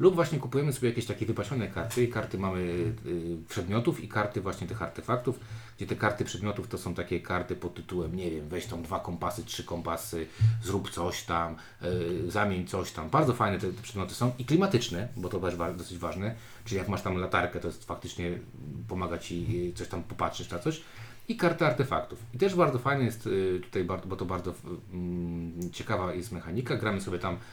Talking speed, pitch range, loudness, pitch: 185 wpm, 90-120 Hz, -32 LUFS, 95 Hz